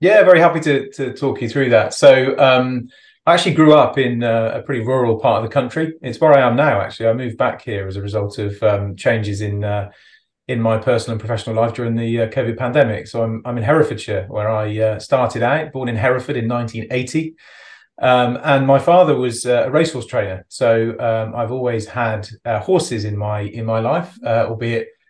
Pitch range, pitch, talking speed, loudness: 110-135 Hz, 120 Hz, 220 wpm, -17 LUFS